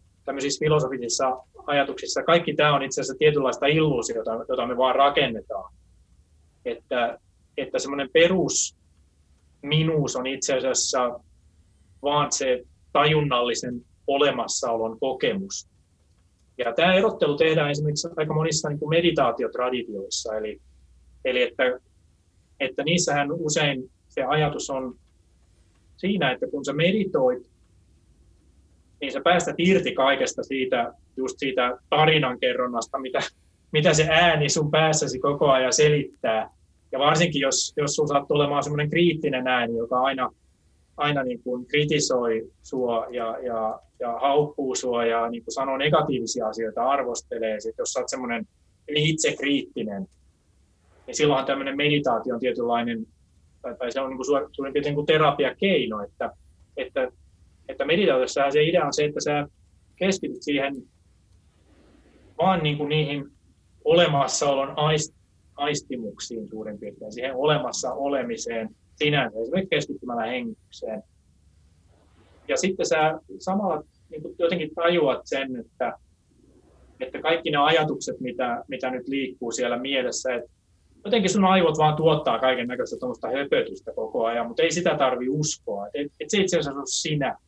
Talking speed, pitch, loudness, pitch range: 125 wpm, 135 Hz, -24 LUFS, 105-150 Hz